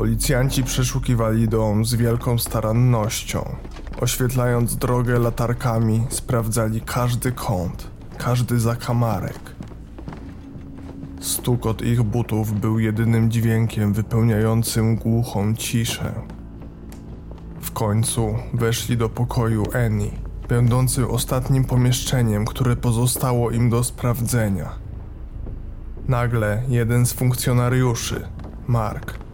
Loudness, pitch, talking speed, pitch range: -21 LUFS, 115 Hz, 90 wpm, 110-120 Hz